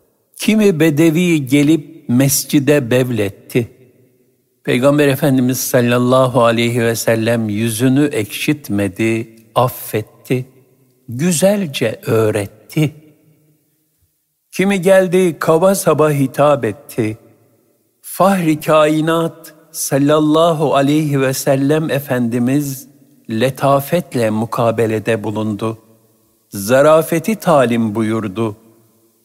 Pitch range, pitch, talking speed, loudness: 115-155 Hz, 135 Hz, 70 wpm, -15 LUFS